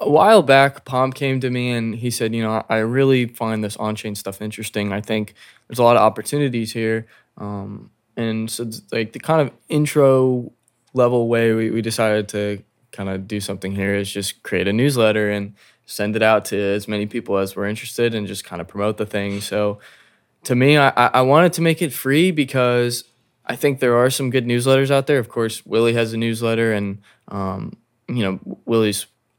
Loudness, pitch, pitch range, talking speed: -19 LUFS, 115 Hz, 105-125 Hz, 210 wpm